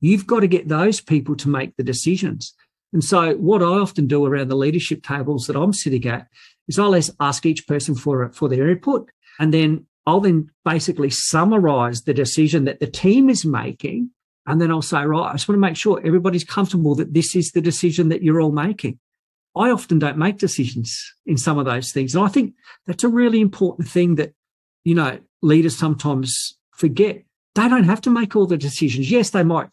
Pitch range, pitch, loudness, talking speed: 145-190 Hz, 160 Hz, -19 LUFS, 210 wpm